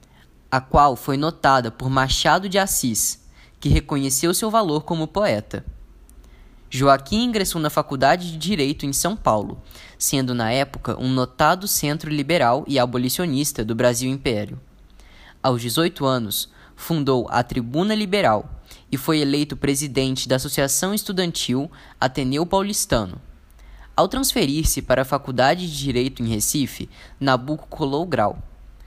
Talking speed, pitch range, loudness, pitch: 130 wpm, 125-160 Hz, -21 LUFS, 135 Hz